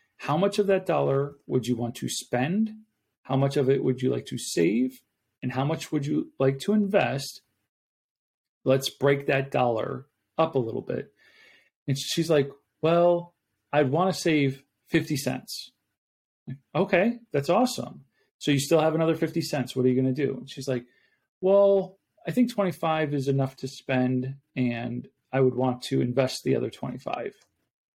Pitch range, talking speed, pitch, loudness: 130-165 Hz, 175 wpm, 140 Hz, -26 LUFS